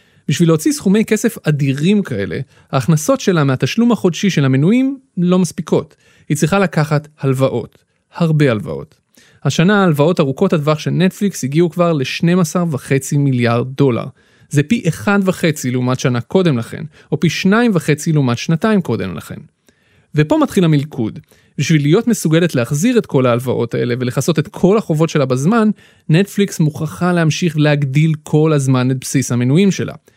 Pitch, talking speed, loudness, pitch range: 155 Hz, 145 wpm, -15 LUFS, 140-185 Hz